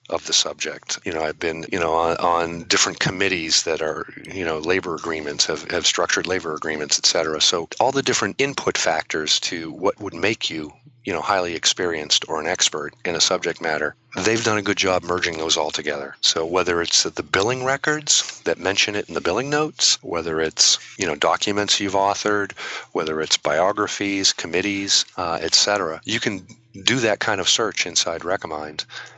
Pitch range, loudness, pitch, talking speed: 85-110 Hz, -20 LUFS, 100 Hz, 190 wpm